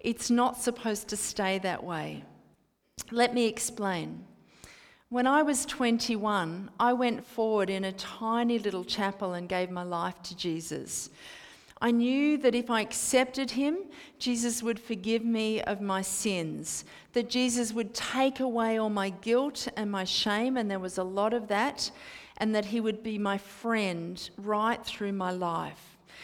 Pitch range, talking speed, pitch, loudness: 195-240 Hz, 160 wpm, 220 Hz, -30 LUFS